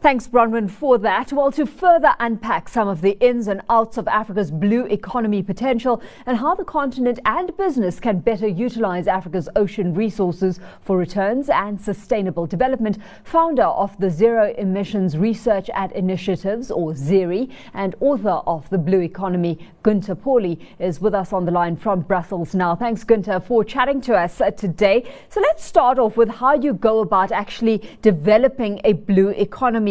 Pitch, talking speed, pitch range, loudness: 210 Hz, 170 wpm, 190-245 Hz, -19 LUFS